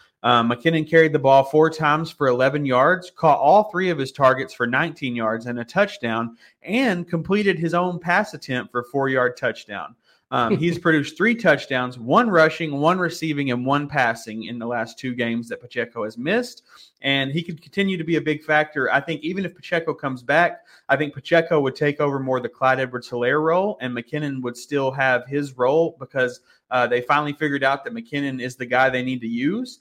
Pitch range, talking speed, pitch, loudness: 125-165 Hz, 205 wpm, 145 Hz, -21 LUFS